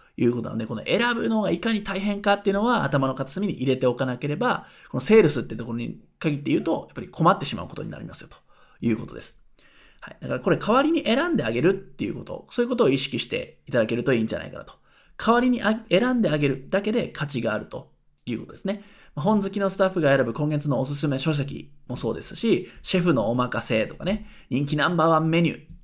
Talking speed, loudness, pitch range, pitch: 480 characters per minute, -24 LUFS, 135-205 Hz, 160 Hz